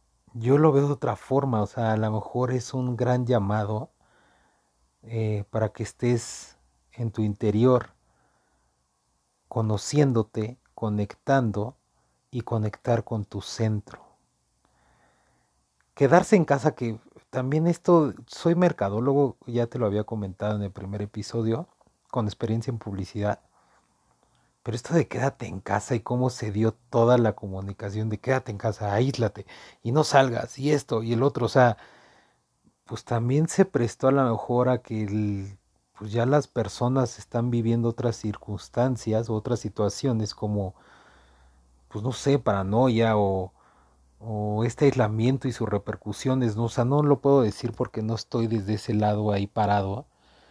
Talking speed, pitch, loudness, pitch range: 150 wpm, 115 Hz, -26 LUFS, 105-125 Hz